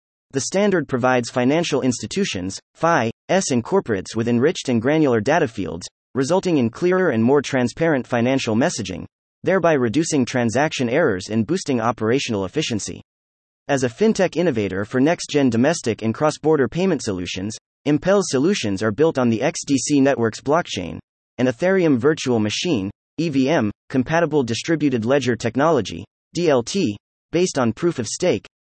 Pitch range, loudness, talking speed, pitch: 115-160 Hz, -20 LUFS, 135 wpm, 130 Hz